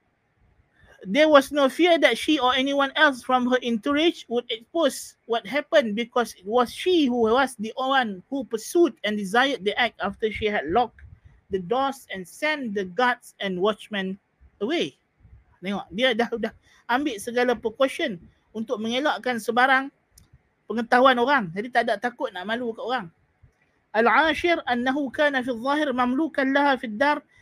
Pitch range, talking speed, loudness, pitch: 225-280 Hz, 160 wpm, -23 LUFS, 250 Hz